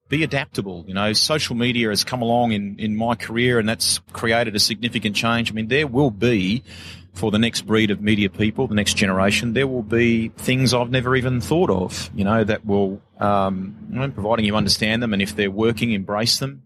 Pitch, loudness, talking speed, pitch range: 110 Hz, -20 LUFS, 210 wpm, 100-120 Hz